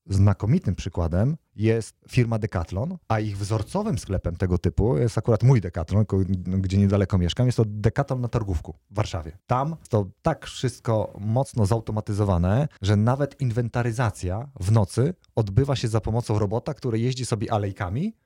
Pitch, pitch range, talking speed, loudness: 110 Hz, 100-125 Hz, 150 wpm, -25 LUFS